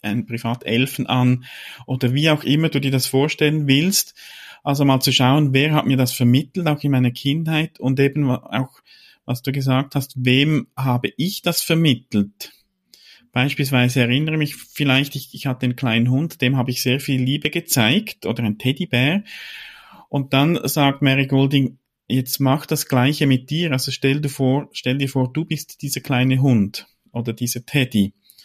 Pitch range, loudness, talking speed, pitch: 125-145 Hz, -19 LUFS, 175 wpm, 135 Hz